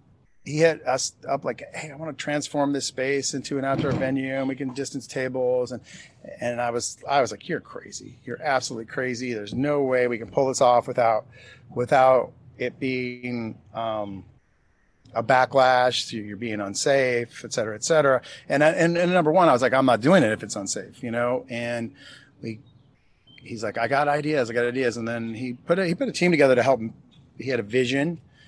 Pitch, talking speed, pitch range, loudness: 130 Hz, 210 wpm, 120-140 Hz, -24 LUFS